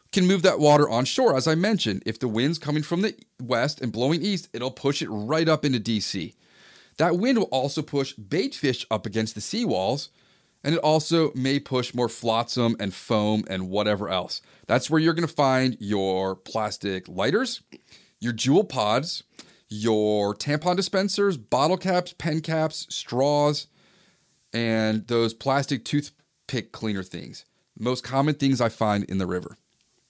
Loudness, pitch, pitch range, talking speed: -25 LUFS, 130 Hz, 110-155 Hz, 165 wpm